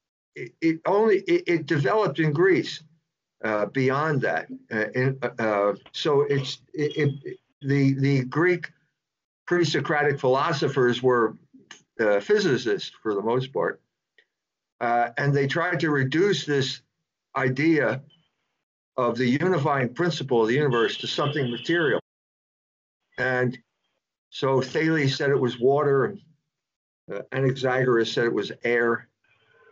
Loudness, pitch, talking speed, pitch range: -24 LUFS, 140 Hz, 120 wpm, 130-165 Hz